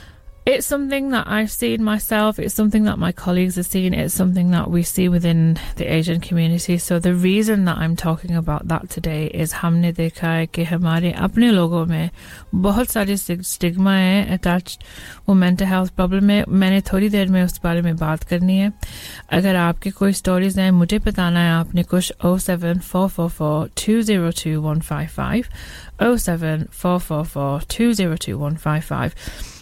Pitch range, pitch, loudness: 165-195 Hz, 180 Hz, -19 LUFS